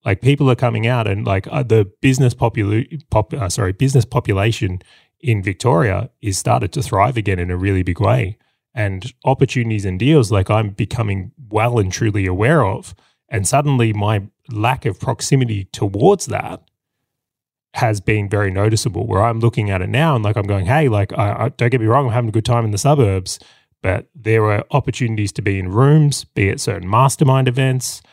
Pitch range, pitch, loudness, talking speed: 100-130 Hz, 115 Hz, -17 LUFS, 190 wpm